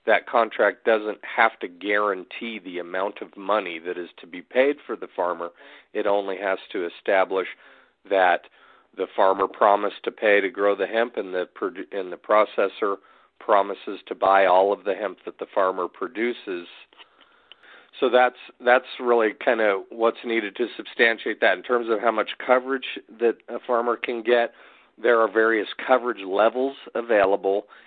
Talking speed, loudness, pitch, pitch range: 165 wpm, -23 LUFS, 110 Hz, 95-120 Hz